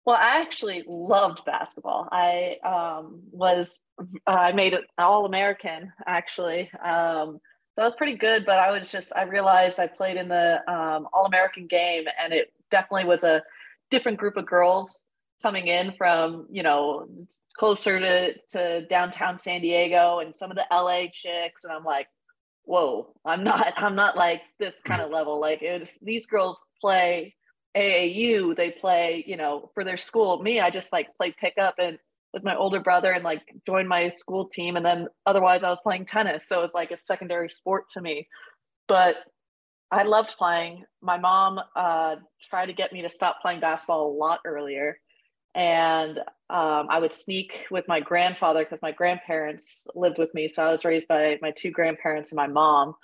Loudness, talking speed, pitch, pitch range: -24 LUFS, 185 wpm, 180 Hz, 165-190 Hz